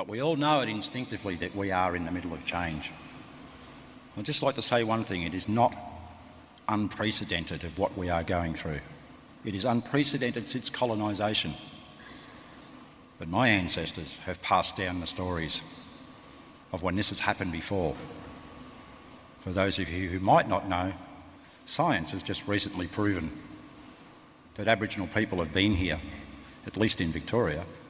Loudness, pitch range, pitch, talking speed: -29 LUFS, 90-110 Hz, 100 Hz, 155 wpm